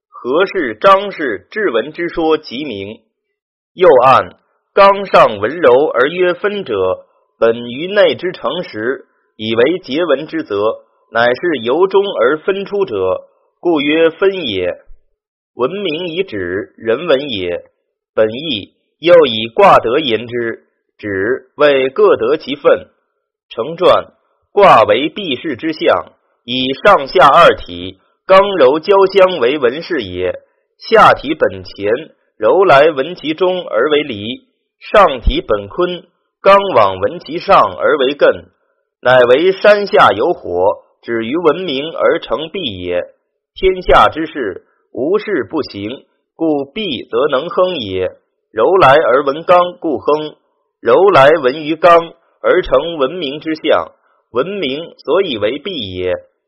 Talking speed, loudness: 175 characters per minute, -13 LUFS